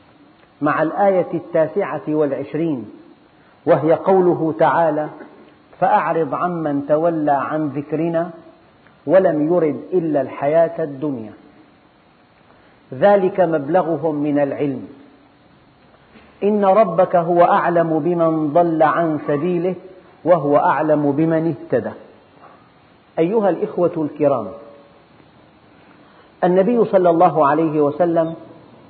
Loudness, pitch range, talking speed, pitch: -17 LUFS, 150-175 Hz, 85 wpm, 165 Hz